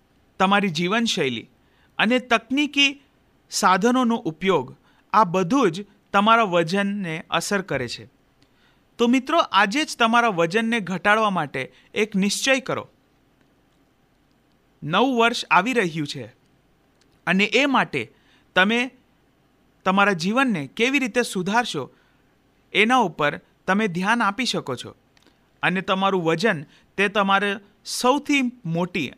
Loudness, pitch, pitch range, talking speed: -21 LUFS, 200 Hz, 170-235 Hz, 110 wpm